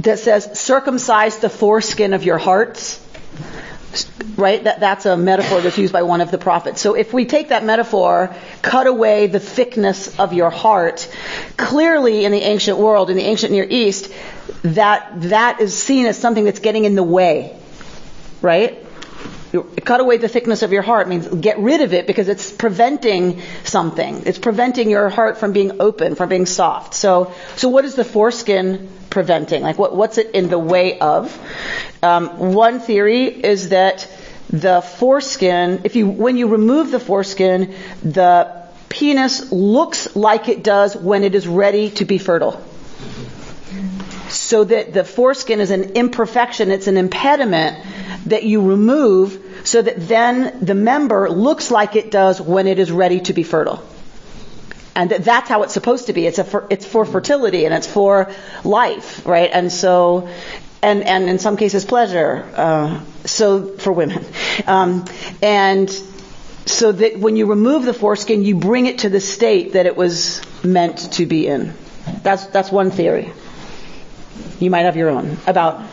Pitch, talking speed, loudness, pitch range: 200 Hz, 170 wpm, -15 LUFS, 185-220 Hz